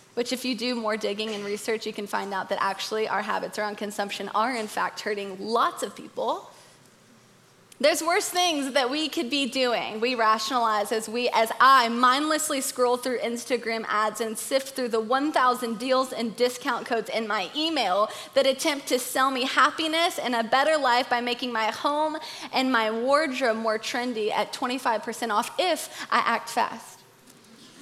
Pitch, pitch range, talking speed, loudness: 245 Hz, 220-275 Hz, 175 wpm, -25 LUFS